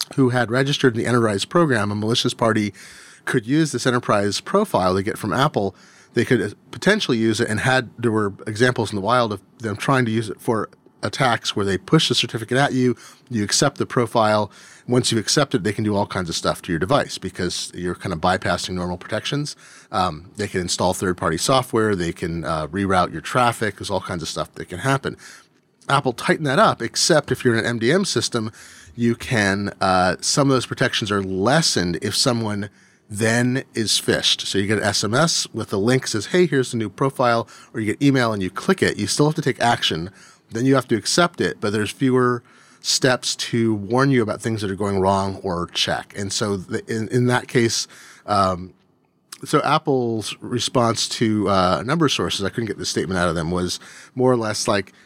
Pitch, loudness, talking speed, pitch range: 115 Hz, -20 LUFS, 215 wpm, 100-125 Hz